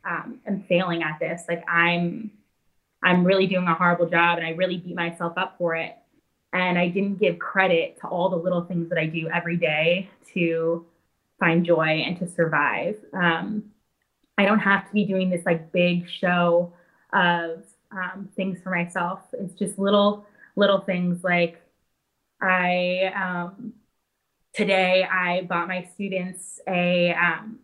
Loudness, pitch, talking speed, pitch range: -23 LUFS, 180 Hz, 160 wpm, 170-195 Hz